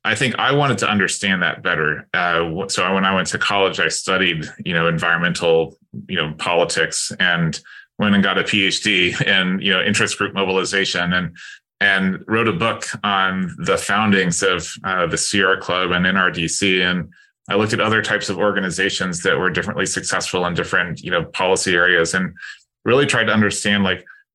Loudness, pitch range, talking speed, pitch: -18 LUFS, 90-100 Hz, 180 wpm, 95 Hz